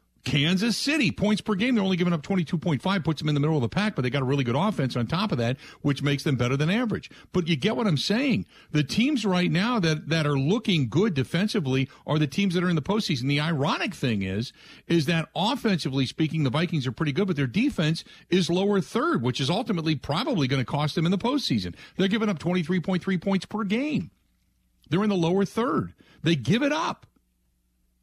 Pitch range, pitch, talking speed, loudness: 140-200 Hz, 170 Hz, 225 wpm, -25 LUFS